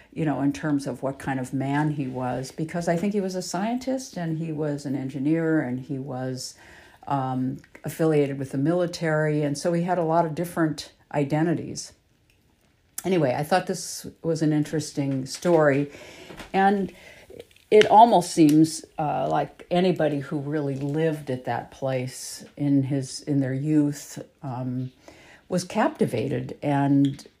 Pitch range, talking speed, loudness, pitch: 135-170 Hz, 155 wpm, -25 LUFS, 150 Hz